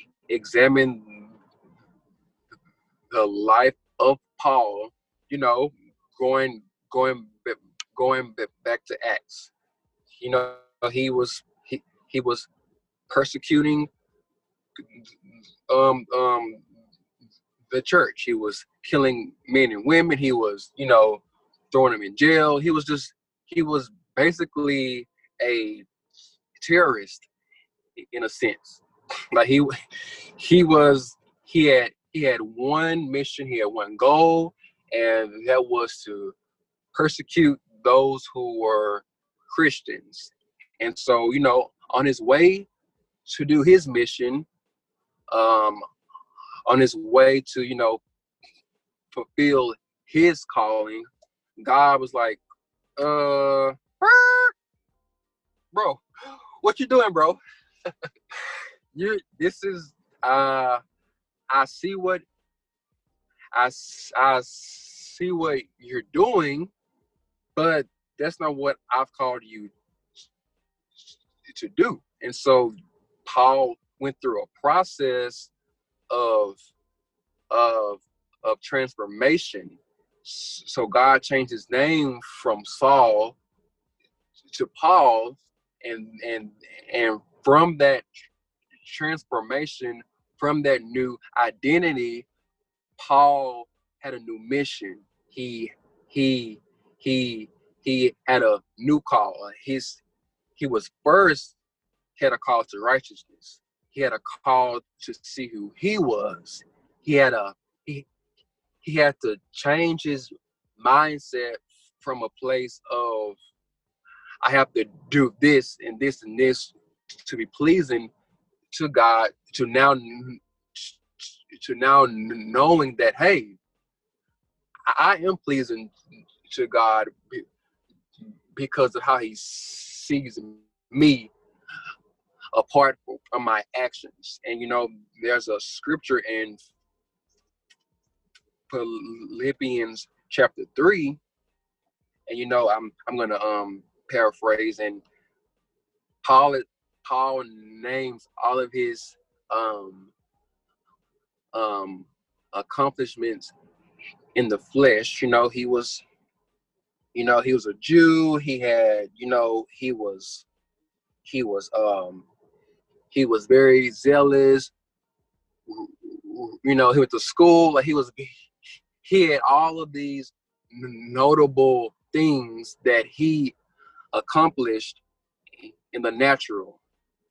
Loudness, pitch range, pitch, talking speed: -22 LUFS, 120-170 Hz, 135 Hz, 105 wpm